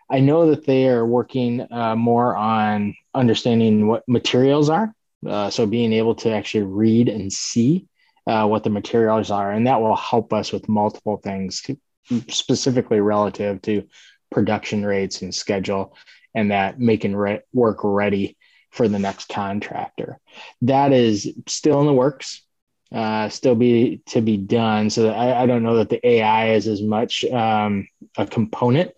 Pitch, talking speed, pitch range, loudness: 110 Hz, 165 wpm, 105-120 Hz, -20 LUFS